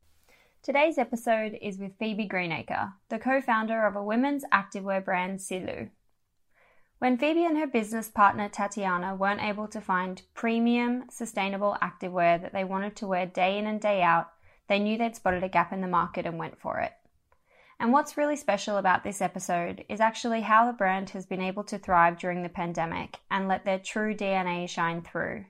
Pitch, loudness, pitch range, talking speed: 200 Hz, -28 LUFS, 185-225 Hz, 185 wpm